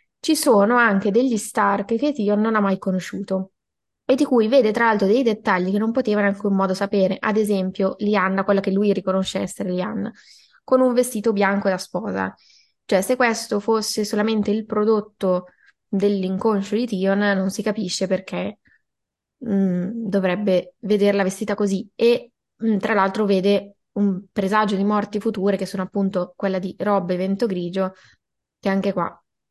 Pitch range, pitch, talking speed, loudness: 190-220 Hz, 205 Hz, 165 wpm, -21 LUFS